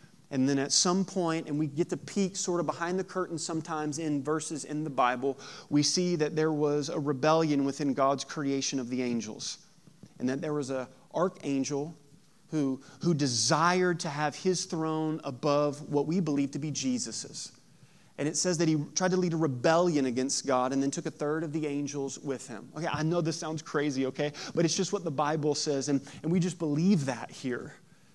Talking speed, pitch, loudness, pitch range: 205 wpm, 150 Hz, -30 LUFS, 140-170 Hz